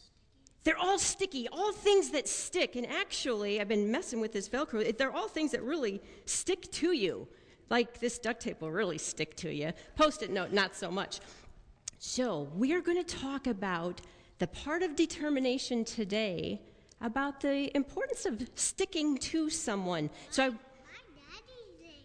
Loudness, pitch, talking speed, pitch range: -33 LUFS, 265 Hz, 160 wpm, 220-330 Hz